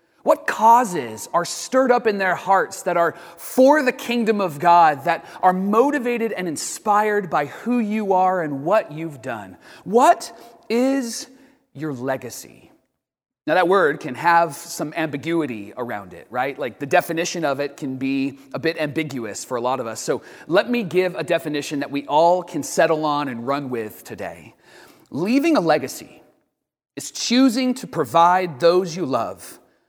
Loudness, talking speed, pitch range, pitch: -20 LUFS, 165 wpm, 145-220 Hz, 170 Hz